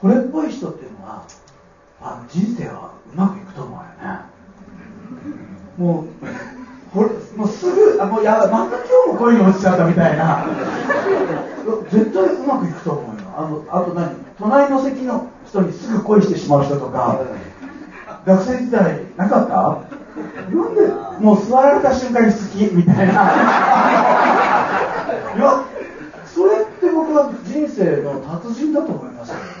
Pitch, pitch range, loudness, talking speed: 215 Hz, 185-270 Hz, -16 LUFS, 275 characters per minute